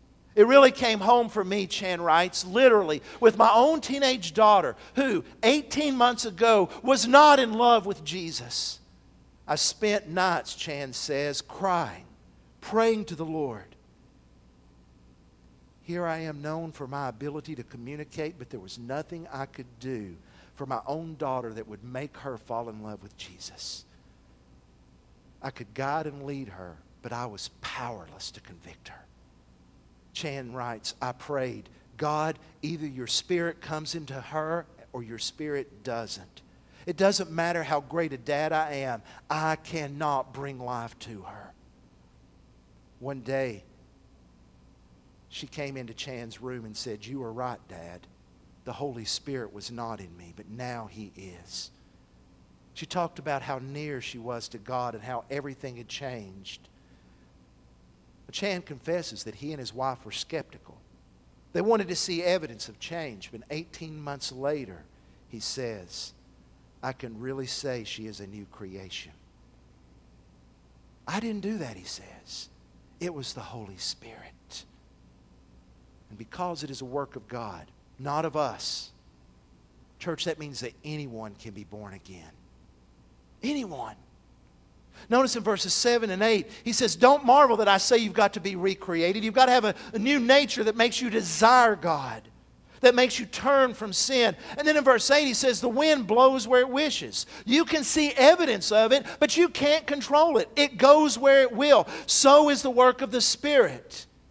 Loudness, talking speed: -25 LUFS, 160 wpm